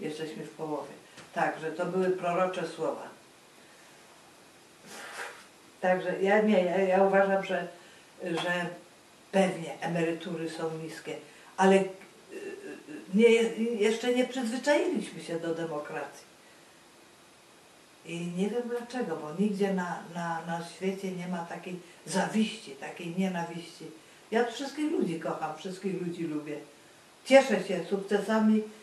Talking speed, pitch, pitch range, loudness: 110 wpm, 180 Hz, 165-205 Hz, -30 LUFS